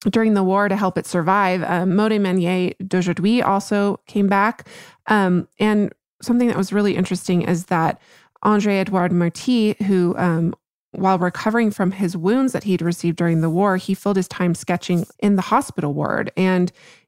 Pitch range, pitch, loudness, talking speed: 180-205 Hz, 190 Hz, -19 LUFS, 170 wpm